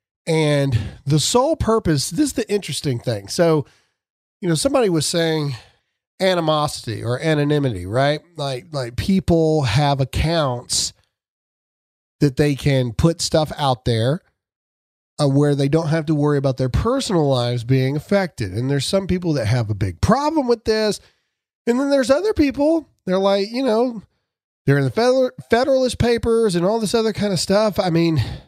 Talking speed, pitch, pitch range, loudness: 160 wpm, 155 Hz, 130-205 Hz, -19 LUFS